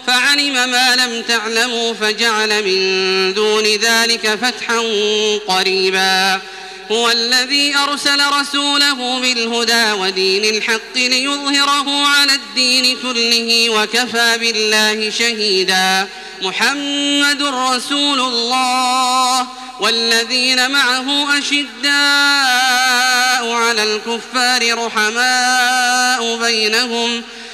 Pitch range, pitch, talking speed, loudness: 215-255 Hz, 235 Hz, 75 wpm, -13 LUFS